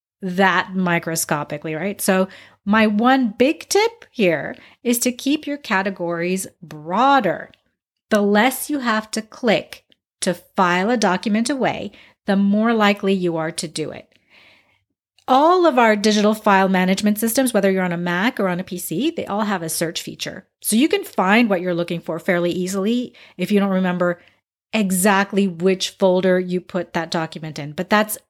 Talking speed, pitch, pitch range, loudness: 170 wpm, 195 Hz, 180-225 Hz, -19 LUFS